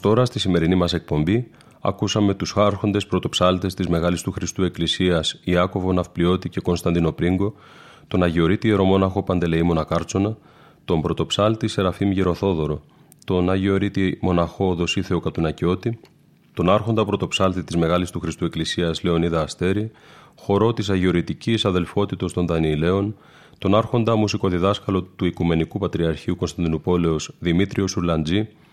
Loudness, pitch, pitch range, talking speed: -21 LUFS, 90 Hz, 85-100 Hz, 120 wpm